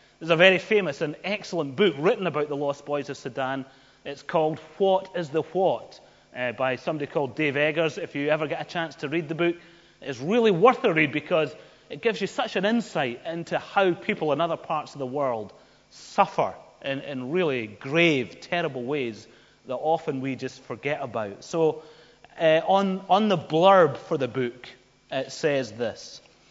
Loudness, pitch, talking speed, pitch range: -25 LUFS, 160 Hz, 185 wpm, 140-180 Hz